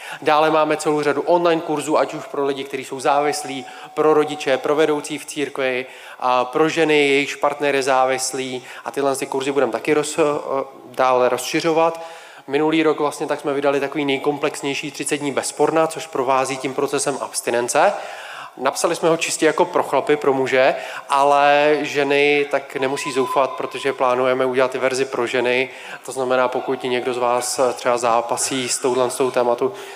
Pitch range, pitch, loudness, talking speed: 130-150 Hz, 140 Hz, -19 LUFS, 170 wpm